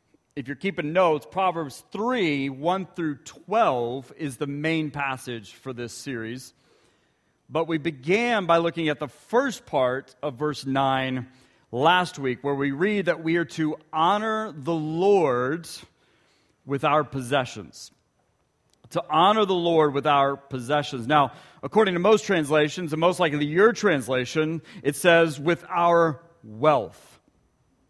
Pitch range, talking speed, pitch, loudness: 140-175 Hz, 140 wpm, 155 Hz, -24 LUFS